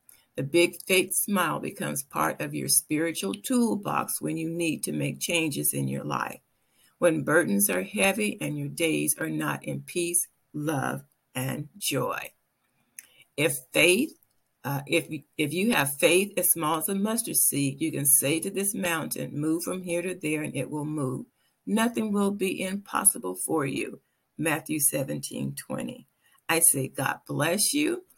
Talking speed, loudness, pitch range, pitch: 160 wpm, -26 LUFS, 140-185 Hz, 160 Hz